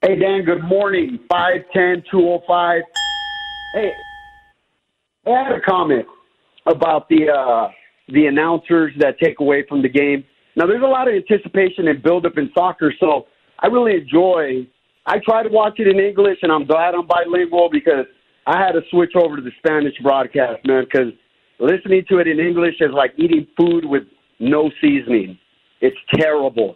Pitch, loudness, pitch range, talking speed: 170 Hz, -16 LUFS, 145-190 Hz, 175 wpm